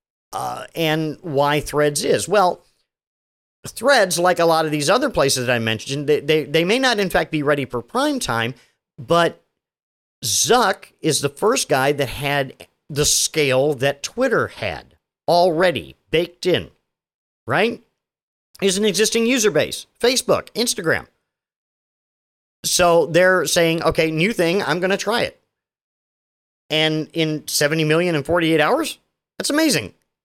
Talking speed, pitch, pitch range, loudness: 145 wpm, 160 Hz, 145-185 Hz, -19 LUFS